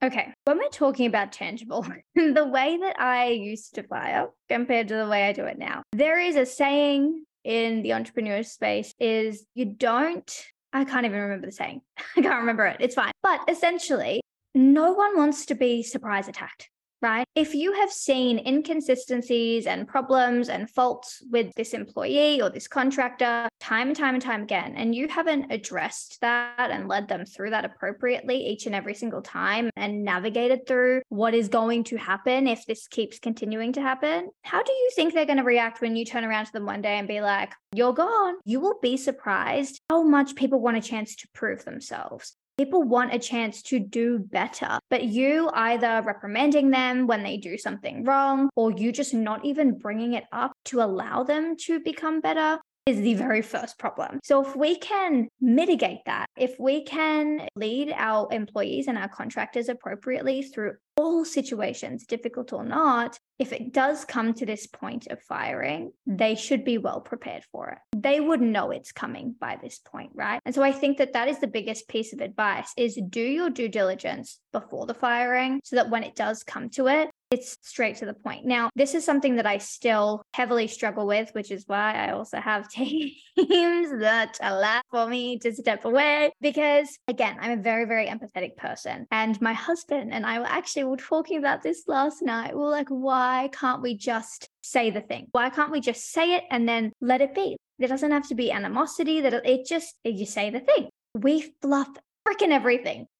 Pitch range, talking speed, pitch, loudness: 225-285 Hz, 195 wpm, 250 Hz, -25 LUFS